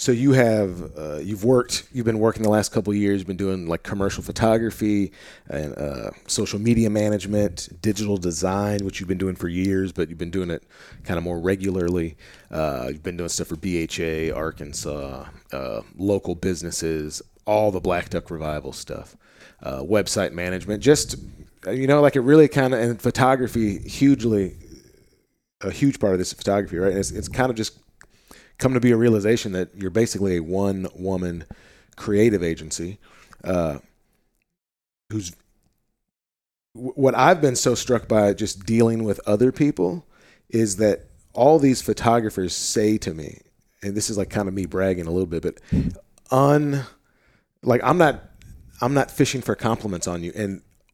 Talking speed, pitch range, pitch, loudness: 170 wpm, 90-115 Hz, 100 Hz, -22 LUFS